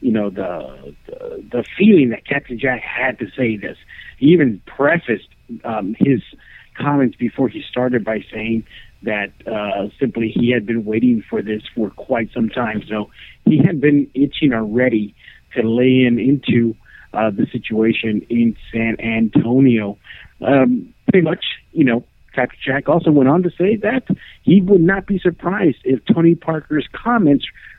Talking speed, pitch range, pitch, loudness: 160 wpm, 115-160 Hz, 125 Hz, -17 LUFS